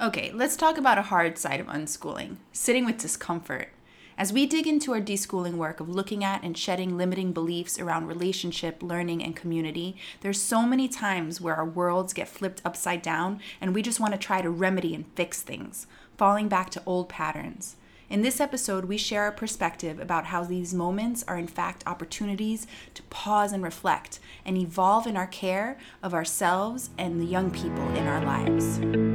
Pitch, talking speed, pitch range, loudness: 185 Hz, 185 wpm, 170-205 Hz, -28 LUFS